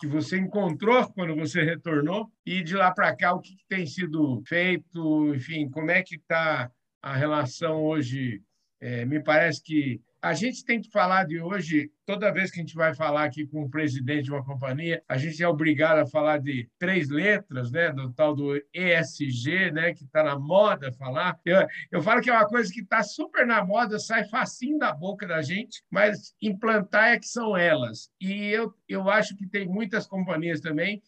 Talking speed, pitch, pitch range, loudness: 200 wpm, 170 Hz, 150-205 Hz, -25 LUFS